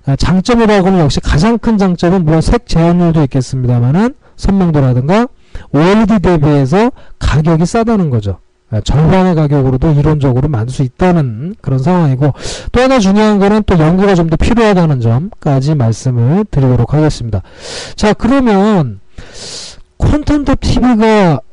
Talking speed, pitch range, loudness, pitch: 330 characters per minute, 135-205 Hz, -11 LUFS, 165 Hz